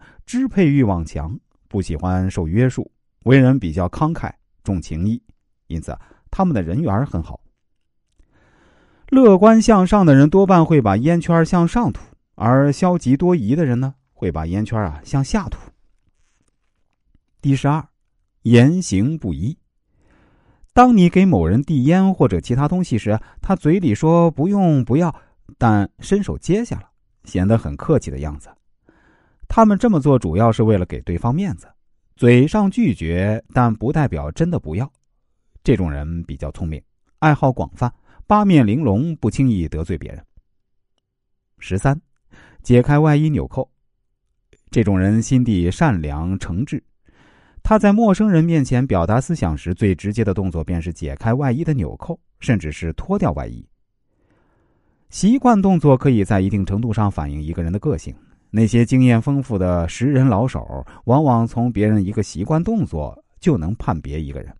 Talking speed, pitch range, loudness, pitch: 235 characters per minute, 90-150 Hz, -17 LUFS, 115 Hz